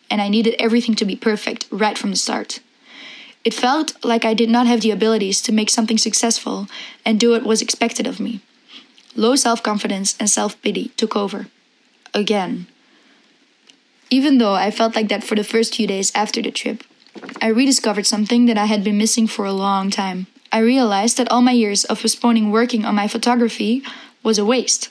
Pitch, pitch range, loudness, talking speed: 230 Hz, 215-250 Hz, -17 LUFS, 195 wpm